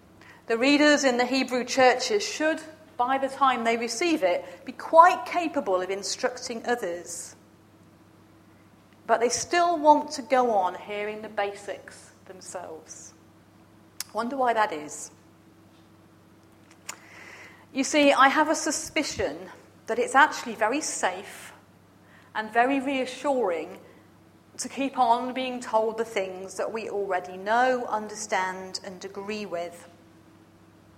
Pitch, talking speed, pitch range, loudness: 230 Hz, 120 wpm, 185-270 Hz, -25 LUFS